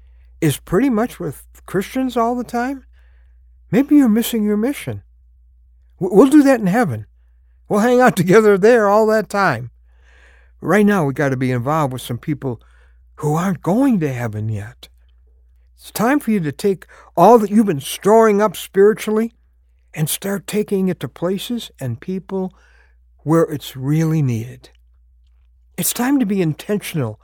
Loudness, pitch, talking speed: -17 LUFS, 155 Hz, 160 wpm